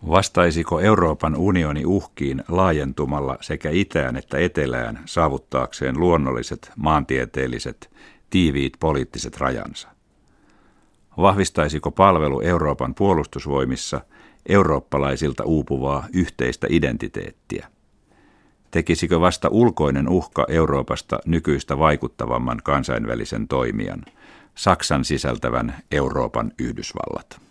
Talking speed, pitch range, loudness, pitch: 80 wpm, 70-85 Hz, -21 LUFS, 75 Hz